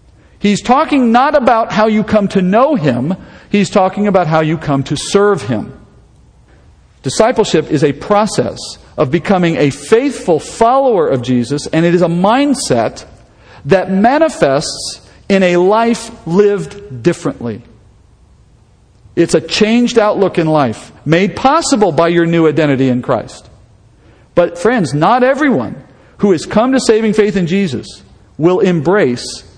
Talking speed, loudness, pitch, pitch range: 140 wpm, -12 LUFS, 180 Hz, 140-215 Hz